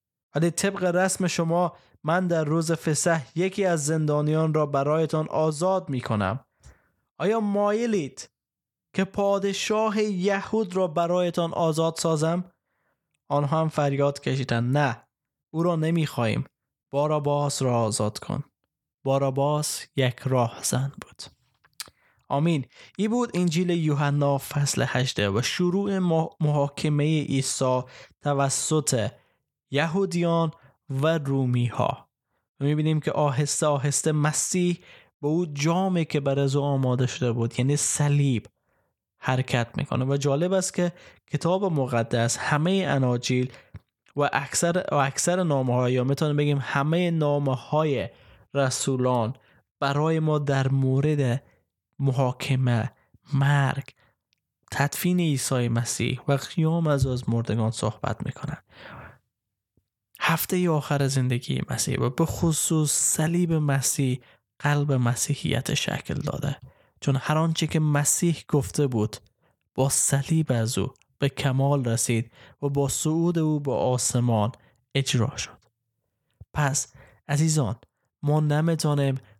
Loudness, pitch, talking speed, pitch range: -25 LUFS, 145 Hz, 115 wpm, 130-160 Hz